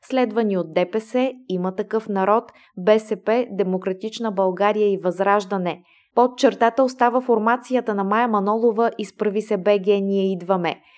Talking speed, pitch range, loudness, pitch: 125 wpm, 195-230 Hz, -21 LUFS, 210 Hz